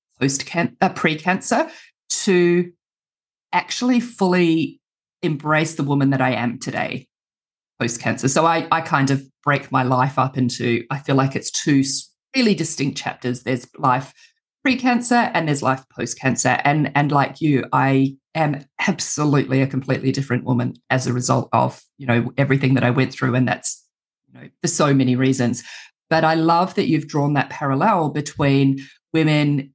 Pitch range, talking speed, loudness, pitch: 130-165 Hz, 160 wpm, -19 LUFS, 140 Hz